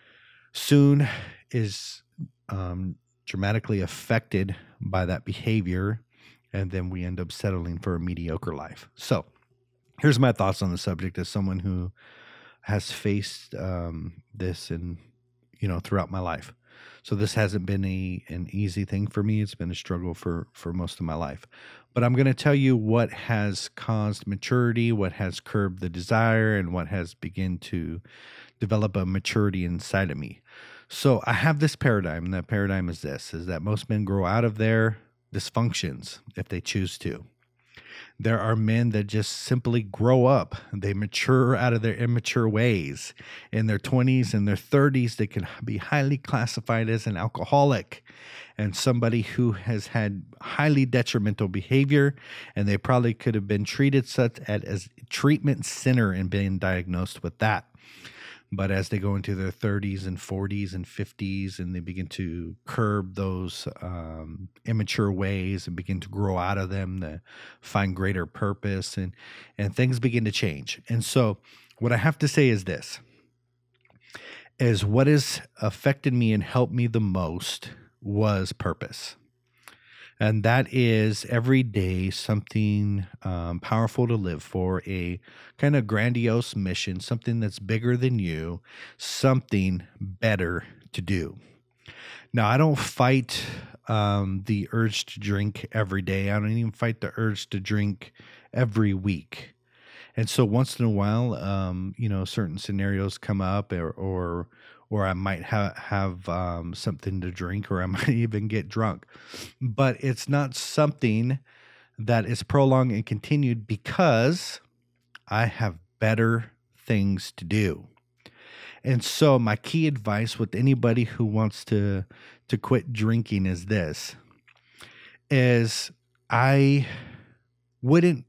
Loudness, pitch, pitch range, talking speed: -26 LUFS, 105 Hz, 95-120 Hz, 155 wpm